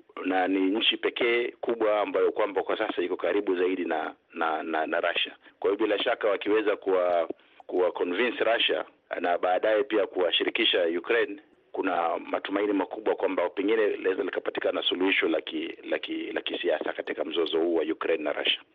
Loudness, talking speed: -27 LUFS, 150 wpm